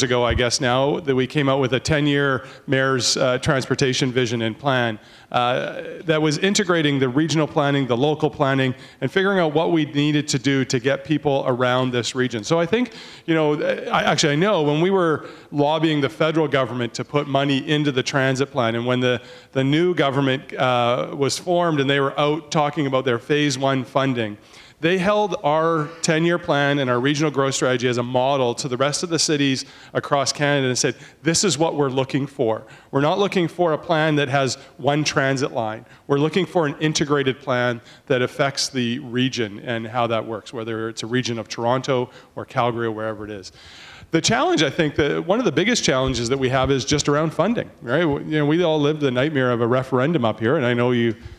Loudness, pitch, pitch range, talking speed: -20 LUFS, 140 Hz, 125-155 Hz, 220 wpm